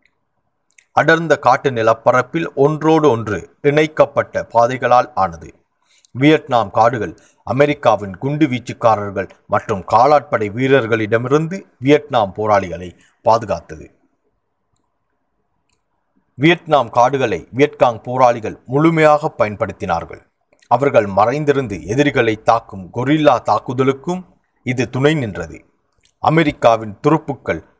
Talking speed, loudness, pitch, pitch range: 75 wpm, -16 LUFS, 135 Hz, 115-150 Hz